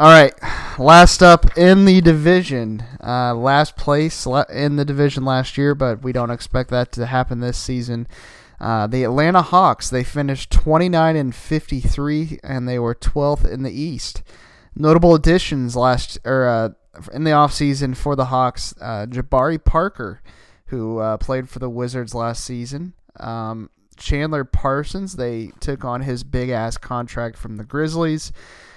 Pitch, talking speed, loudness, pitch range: 130 Hz, 155 wpm, -17 LUFS, 120-150 Hz